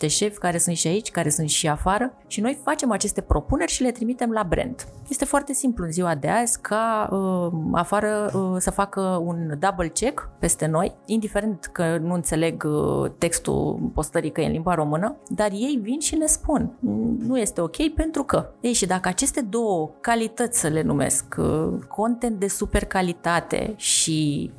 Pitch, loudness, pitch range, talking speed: 205 Hz, -23 LUFS, 170-240 Hz, 180 wpm